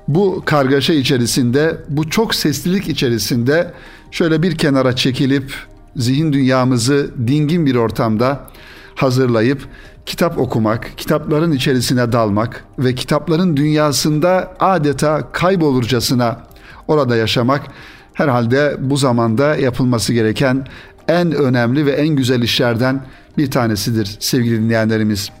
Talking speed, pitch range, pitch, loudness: 105 wpm, 120-150 Hz, 135 Hz, -15 LUFS